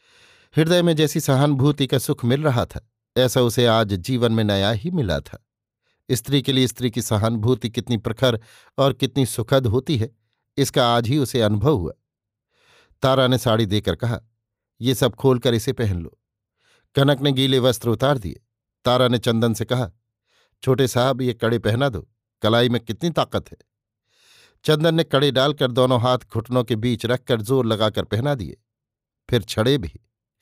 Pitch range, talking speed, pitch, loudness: 115-135 Hz, 170 wpm, 125 Hz, -20 LUFS